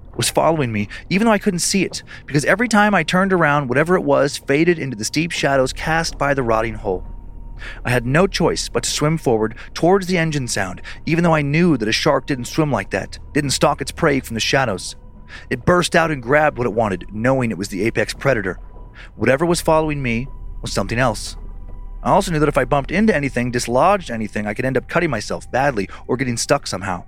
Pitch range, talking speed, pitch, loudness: 110-160 Hz, 225 wpm, 135 Hz, -18 LUFS